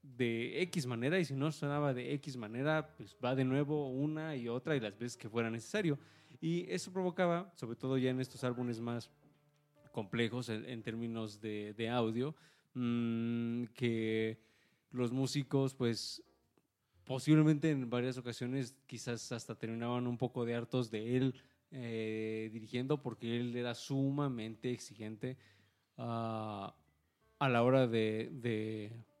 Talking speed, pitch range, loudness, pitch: 145 wpm, 115-140 Hz, -38 LUFS, 125 Hz